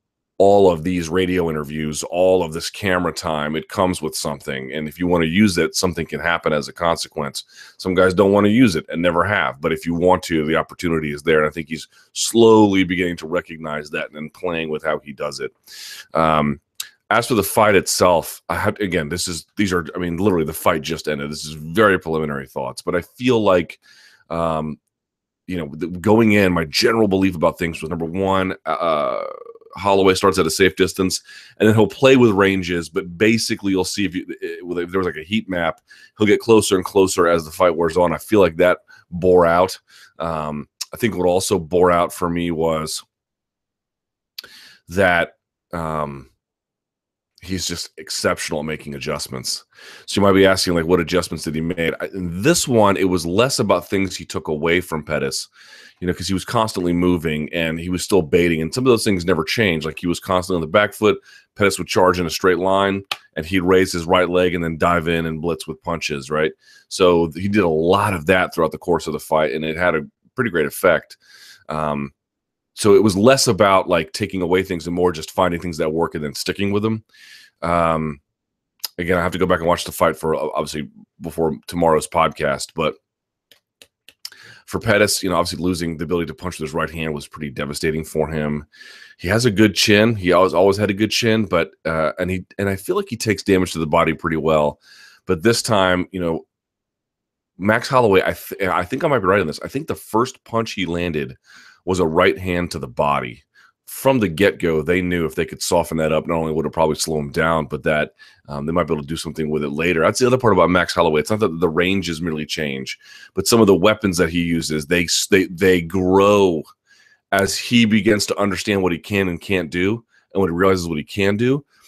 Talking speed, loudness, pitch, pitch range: 225 wpm, -19 LUFS, 90 Hz, 80-100 Hz